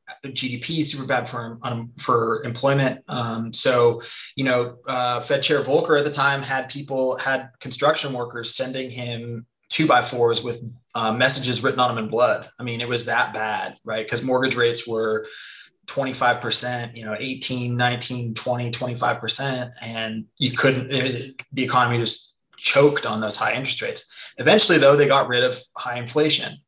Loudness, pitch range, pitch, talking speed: -21 LUFS, 120-135 Hz, 125 Hz, 170 wpm